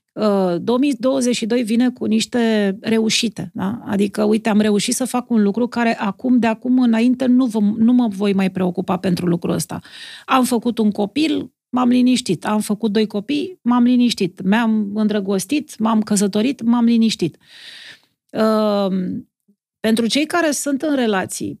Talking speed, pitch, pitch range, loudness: 150 wpm, 225 Hz, 205-245 Hz, -18 LUFS